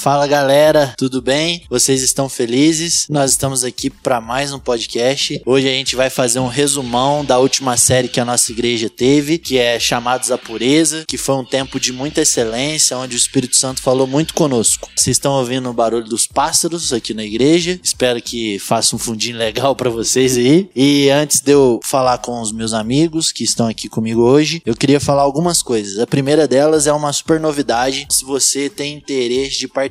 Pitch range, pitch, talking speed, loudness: 120-145 Hz, 130 Hz, 200 wpm, -14 LUFS